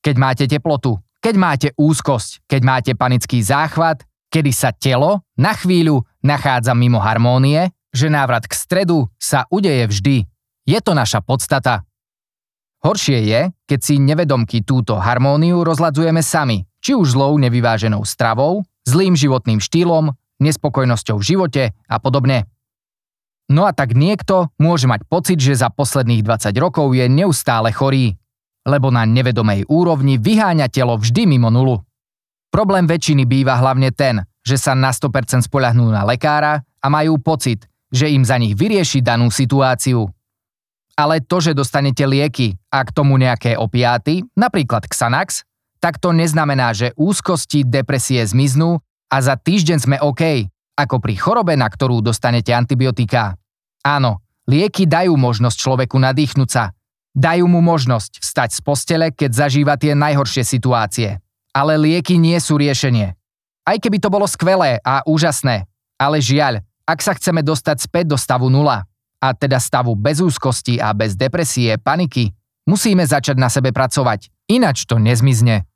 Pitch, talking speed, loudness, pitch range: 135 Hz, 145 wpm, -15 LUFS, 120-155 Hz